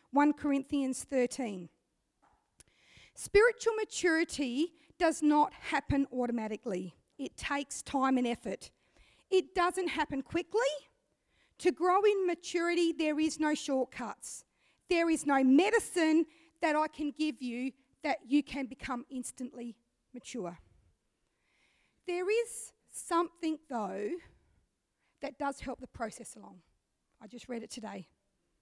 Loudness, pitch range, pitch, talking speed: -32 LUFS, 255-335 Hz, 290 Hz, 115 wpm